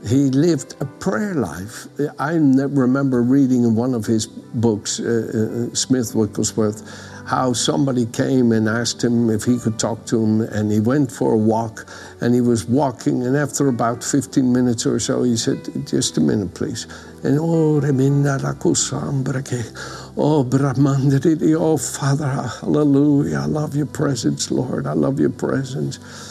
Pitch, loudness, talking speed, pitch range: 130 Hz, -19 LUFS, 150 wpm, 115-140 Hz